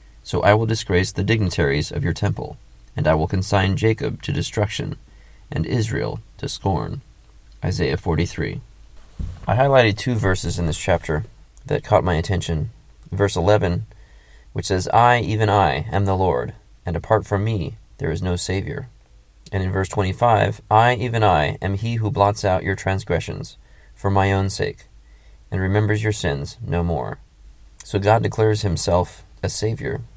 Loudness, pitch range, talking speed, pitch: -21 LUFS, 85-110 Hz, 160 wpm, 95 Hz